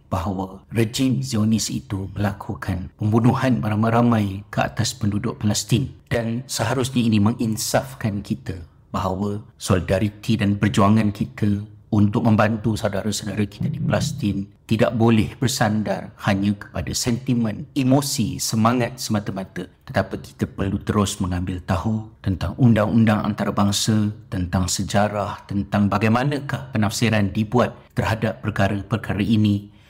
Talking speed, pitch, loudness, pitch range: 110 wpm, 110 Hz, -22 LUFS, 100-115 Hz